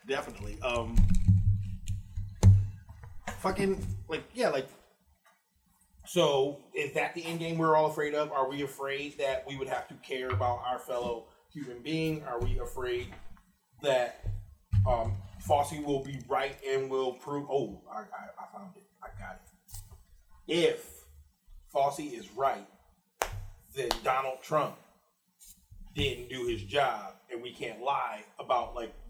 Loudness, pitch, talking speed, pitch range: -32 LUFS, 120 Hz, 140 wpm, 95-140 Hz